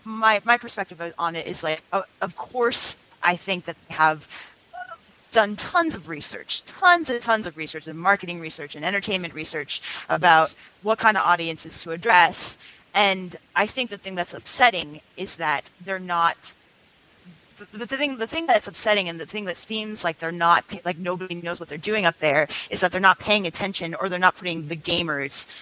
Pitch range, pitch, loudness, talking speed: 165-210 Hz, 180 Hz, -23 LUFS, 190 wpm